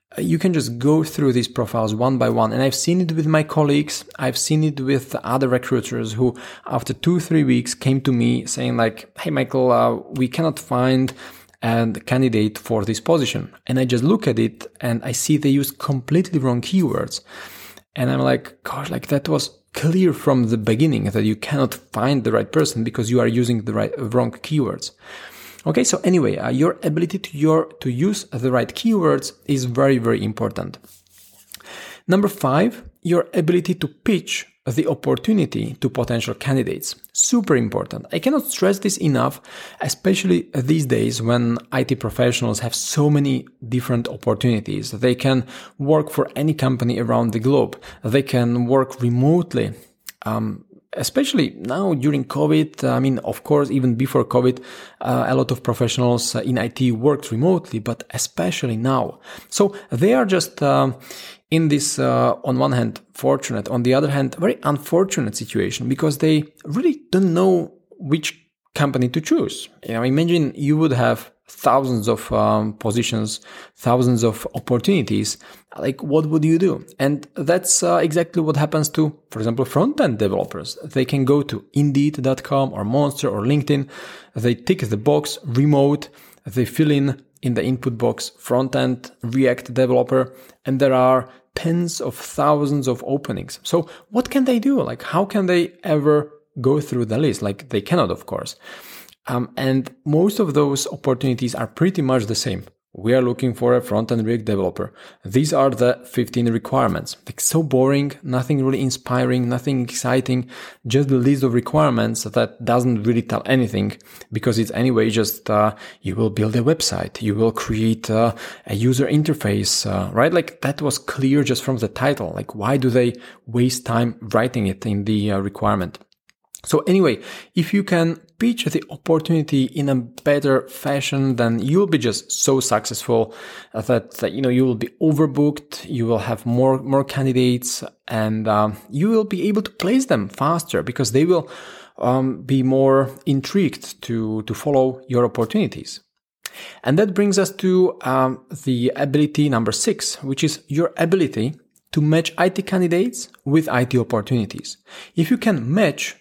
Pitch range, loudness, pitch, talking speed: 120-155 Hz, -20 LUFS, 130 Hz, 170 wpm